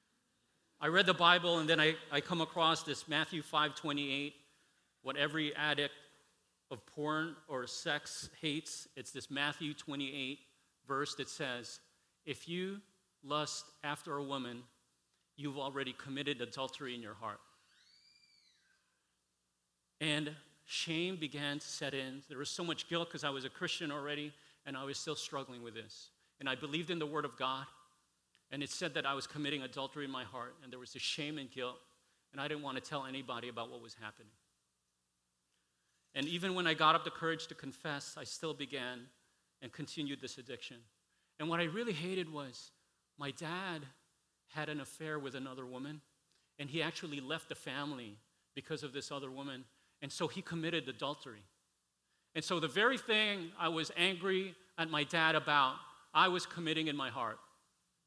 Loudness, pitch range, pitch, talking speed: -38 LUFS, 130-160 Hz, 145 Hz, 175 wpm